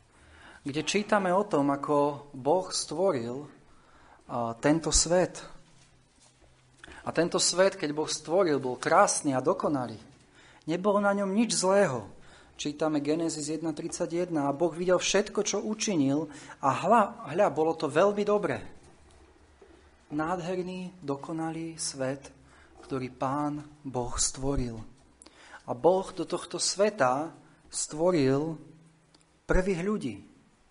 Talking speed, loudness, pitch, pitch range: 105 wpm, -28 LUFS, 160 Hz, 145-185 Hz